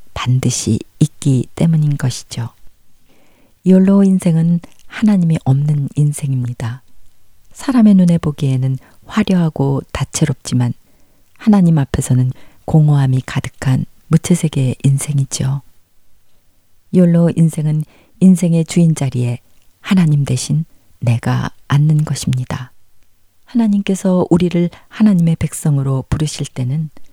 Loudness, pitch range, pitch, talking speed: -15 LUFS, 125-165 Hz, 140 Hz, 250 characters per minute